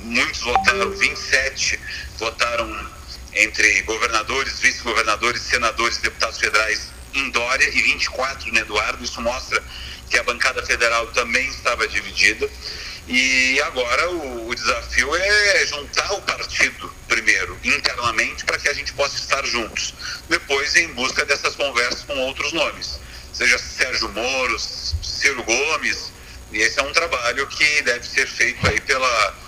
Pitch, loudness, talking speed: 115 Hz, -19 LUFS, 140 wpm